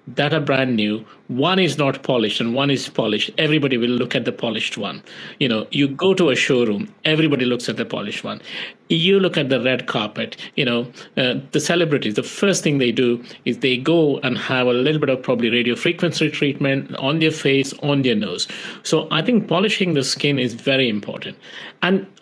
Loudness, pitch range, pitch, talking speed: -19 LUFS, 125-165 Hz, 140 Hz, 210 wpm